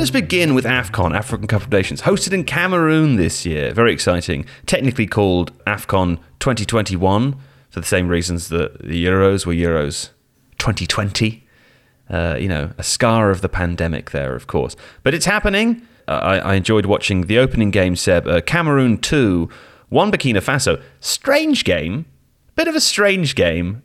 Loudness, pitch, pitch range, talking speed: -17 LUFS, 105 Hz, 90-140 Hz, 165 wpm